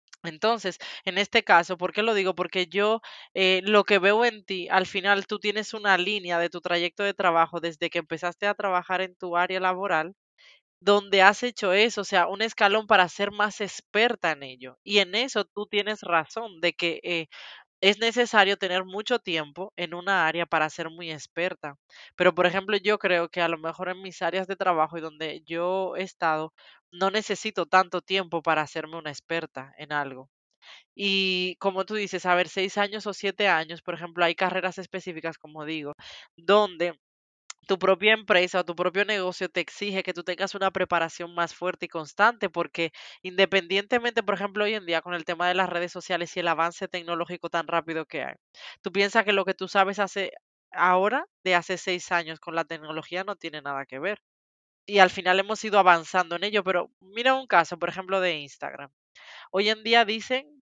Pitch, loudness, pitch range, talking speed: 185 Hz, -25 LUFS, 170-200 Hz, 200 wpm